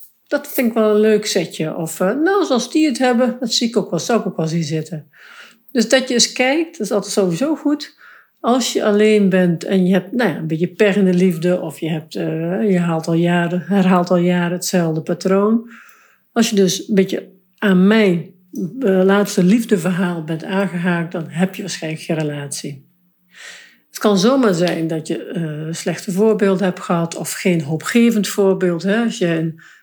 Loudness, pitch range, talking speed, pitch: -17 LUFS, 175-215 Hz, 200 wpm, 190 Hz